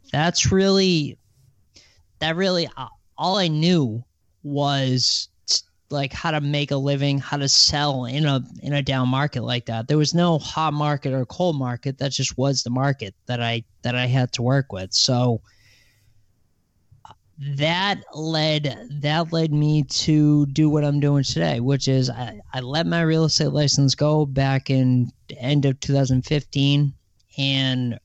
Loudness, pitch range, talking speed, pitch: -21 LUFS, 125-150 Hz, 165 wpm, 140 Hz